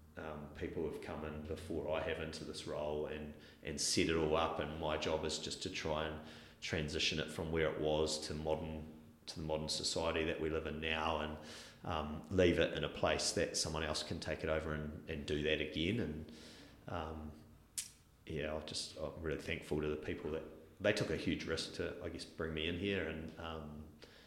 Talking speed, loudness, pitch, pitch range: 220 wpm, -39 LUFS, 80 Hz, 75-80 Hz